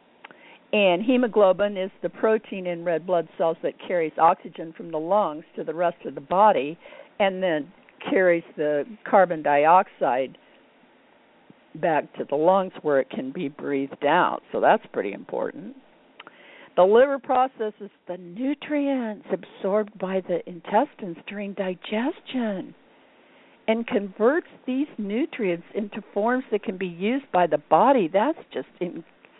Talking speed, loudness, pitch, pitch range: 140 wpm, -24 LUFS, 205 Hz, 175-250 Hz